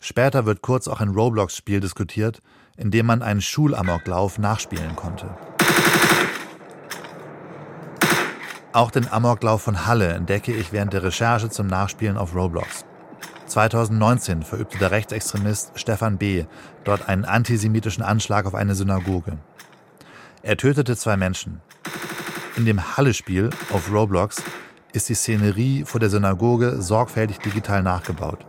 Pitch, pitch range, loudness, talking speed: 105 Hz, 95-115 Hz, -21 LUFS, 125 wpm